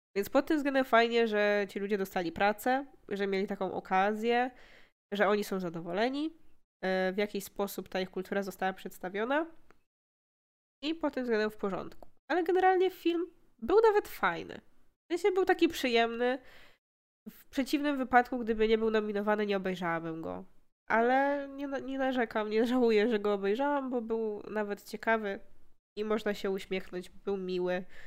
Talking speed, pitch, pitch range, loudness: 155 wpm, 215 Hz, 200-265 Hz, -31 LUFS